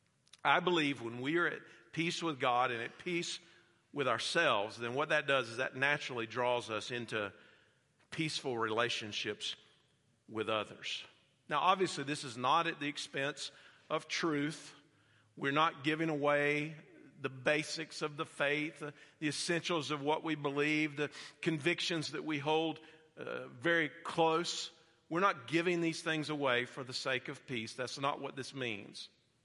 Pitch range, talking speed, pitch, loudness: 130-160 Hz, 155 wpm, 150 Hz, -35 LUFS